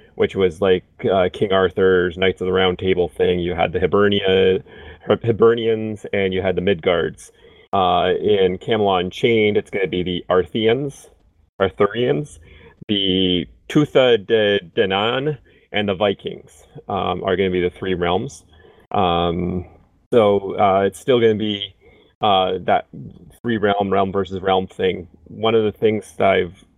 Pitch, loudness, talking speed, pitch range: 95 Hz, -19 LUFS, 155 wpm, 90-110 Hz